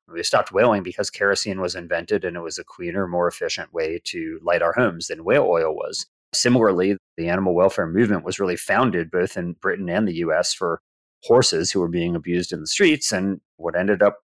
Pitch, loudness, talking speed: 100 Hz, -21 LUFS, 210 wpm